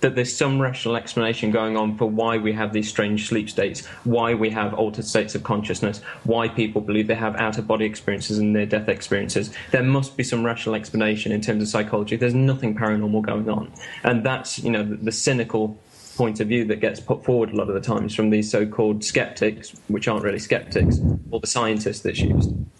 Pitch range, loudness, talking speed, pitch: 105-115 Hz, -23 LUFS, 215 wpm, 110 Hz